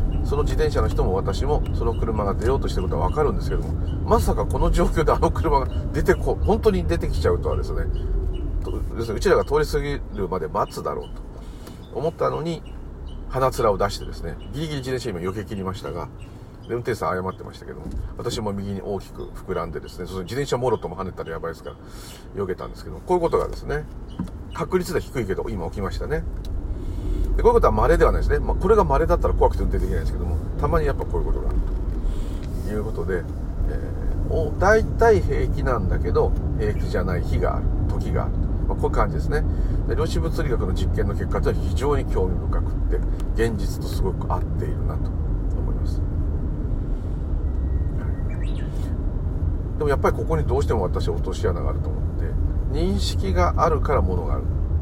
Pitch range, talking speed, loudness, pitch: 80-95 Hz, 405 characters per minute, -24 LUFS, 85 Hz